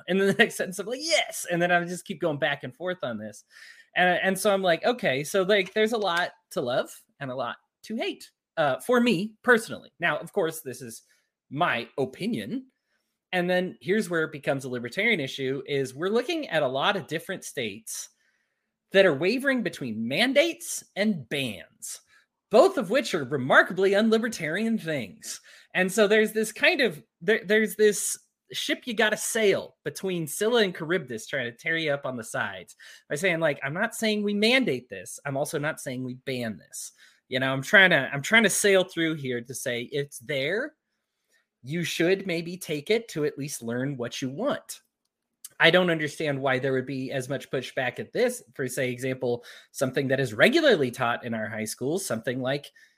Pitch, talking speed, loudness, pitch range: 175 Hz, 200 wpm, -26 LUFS, 135-215 Hz